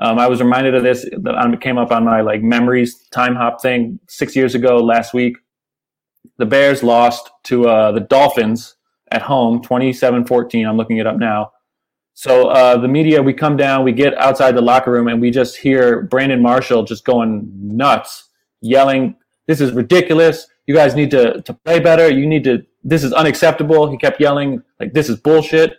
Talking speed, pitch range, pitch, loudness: 195 wpm, 120-145 Hz, 125 Hz, -13 LUFS